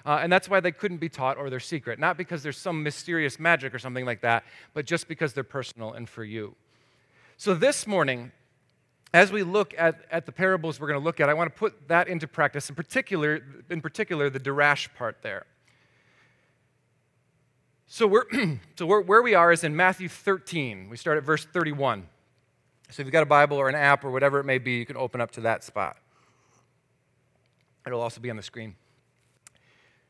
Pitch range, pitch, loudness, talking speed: 130-170 Hz, 145 Hz, -25 LUFS, 205 wpm